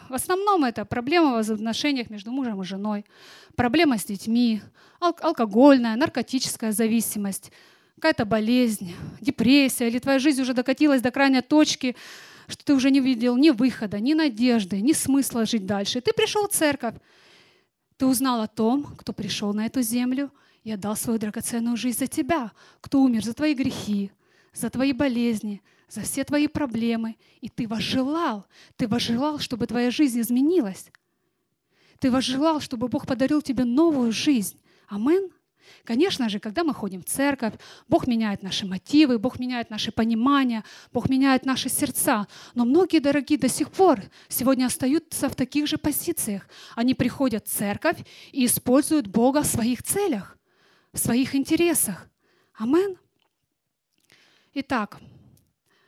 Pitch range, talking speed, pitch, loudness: 225-285 Hz, 145 wpm, 255 Hz, -23 LUFS